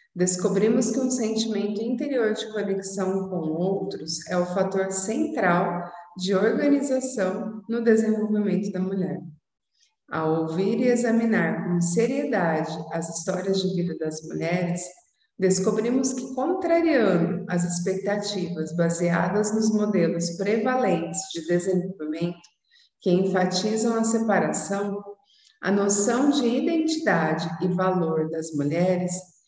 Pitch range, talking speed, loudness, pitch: 175-225 Hz, 110 wpm, -24 LUFS, 195 Hz